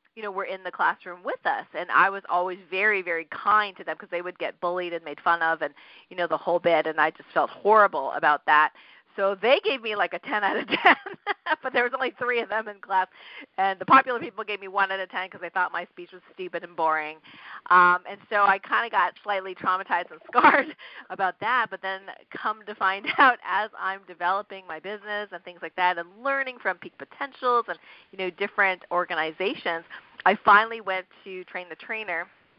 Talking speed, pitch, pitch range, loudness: 225 wpm, 190 Hz, 175-210 Hz, -24 LUFS